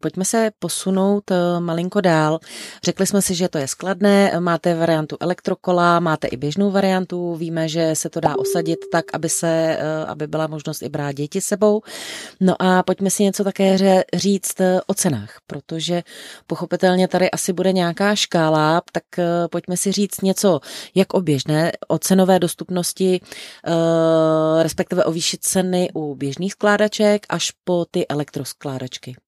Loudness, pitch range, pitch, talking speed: -19 LUFS, 160-190 Hz, 175 Hz, 150 wpm